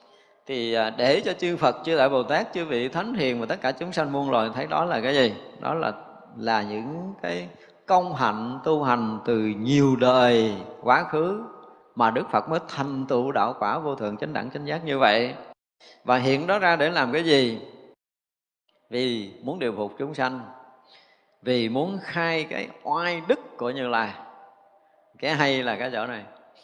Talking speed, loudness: 190 wpm, -24 LUFS